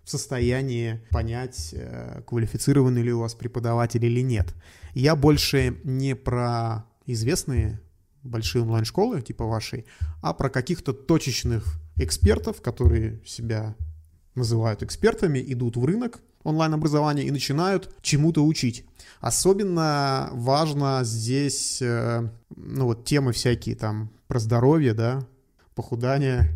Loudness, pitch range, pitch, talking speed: -24 LUFS, 115-135 Hz, 120 Hz, 110 wpm